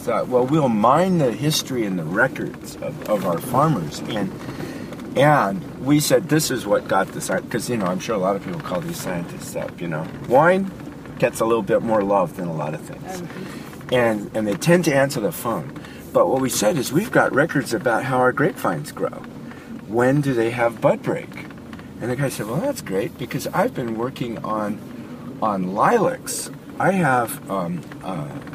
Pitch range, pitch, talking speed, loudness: 115-150 Hz, 130 Hz, 200 wpm, -21 LUFS